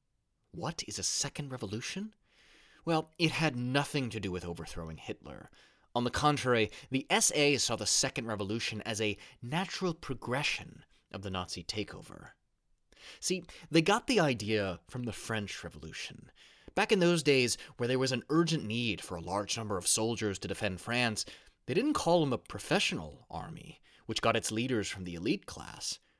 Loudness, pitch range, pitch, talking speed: -32 LUFS, 105-145 Hz, 120 Hz, 170 wpm